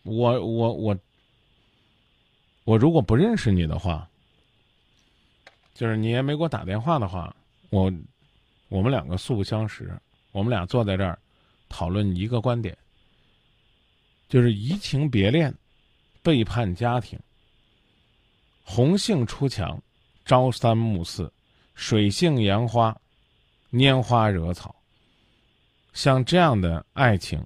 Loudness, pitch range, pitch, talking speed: -23 LUFS, 95-125 Hz, 115 Hz, 170 characters per minute